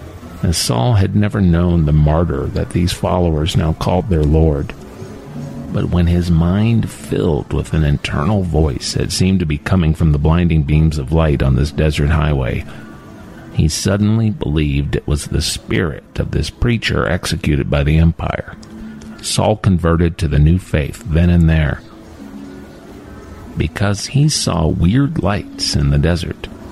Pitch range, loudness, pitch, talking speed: 75-100 Hz, -16 LUFS, 85 Hz, 155 wpm